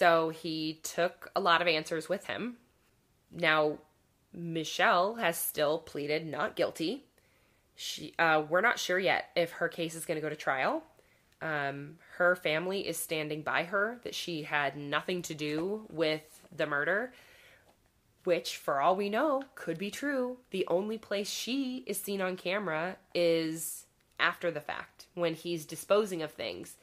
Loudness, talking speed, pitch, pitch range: -32 LUFS, 160 wpm, 170 Hz, 155-195 Hz